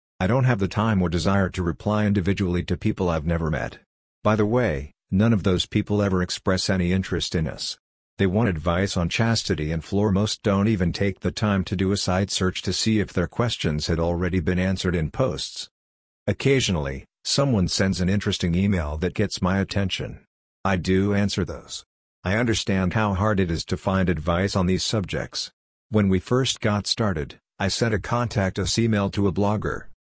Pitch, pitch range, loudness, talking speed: 95 Hz, 90-105 Hz, -23 LUFS, 195 wpm